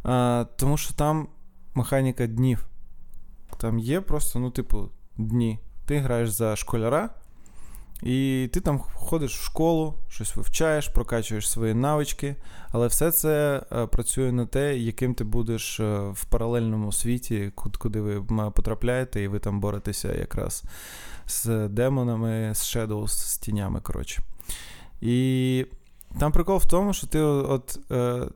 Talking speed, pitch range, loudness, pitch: 130 wpm, 105-135 Hz, -26 LUFS, 120 Hz